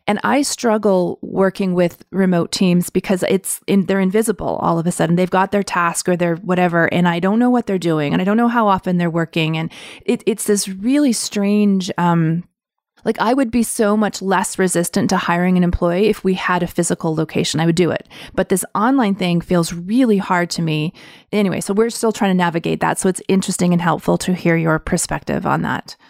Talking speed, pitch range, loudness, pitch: 220 wpm, 175-210 Hz, -17 LUFS, 190 Hz